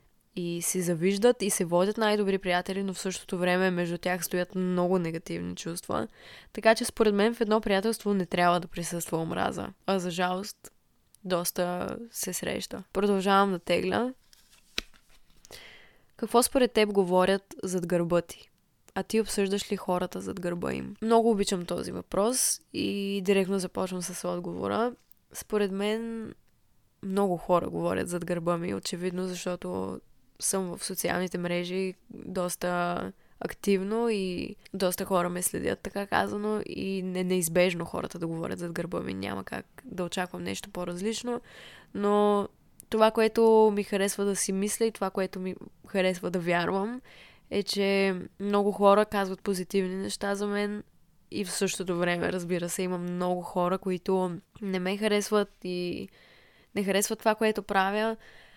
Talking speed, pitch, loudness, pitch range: 150 wpm, 190 Hz, -29 LUFS, 180-205 Hz